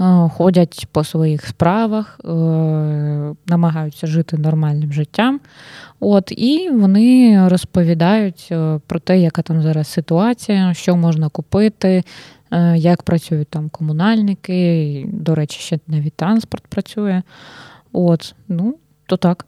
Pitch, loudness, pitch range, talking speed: 170 Hz, -16 LUFS, 155-195 Hz, 110 wpm